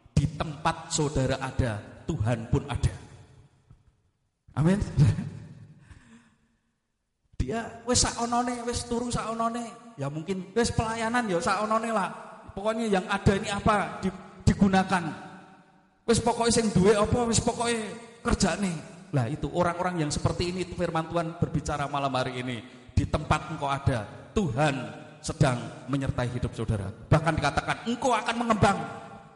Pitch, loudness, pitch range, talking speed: 165 Hz, -28 LUFS, 140-220 Hz, 130 wpm